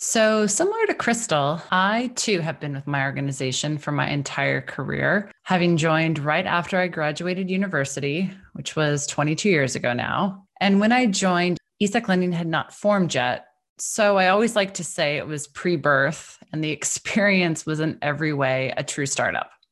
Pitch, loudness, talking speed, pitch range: 165 Hz, -22 LUFS, 175 wpm, 145-195 Hz